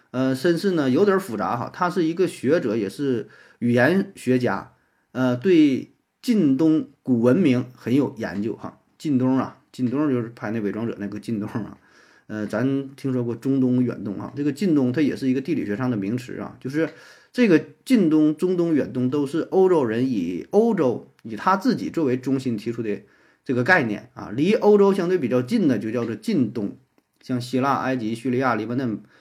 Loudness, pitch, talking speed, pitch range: -22 LUFS, 130 Hz, 280 characters per minute, 120-175 Hz